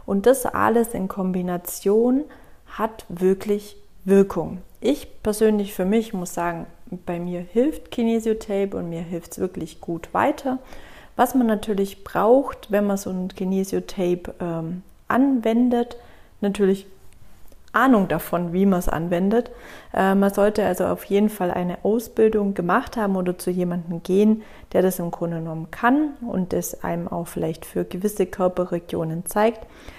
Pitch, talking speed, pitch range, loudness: 195 Hz, 145 wpm, 180-220 Hz, -22 LUFS